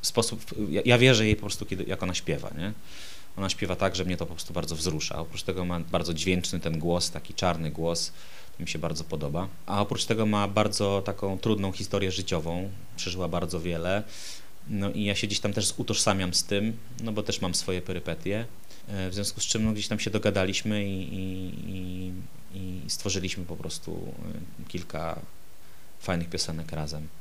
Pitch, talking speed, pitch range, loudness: 95 Hz, 185 wpm, 85-105 Hz, -29 LUFS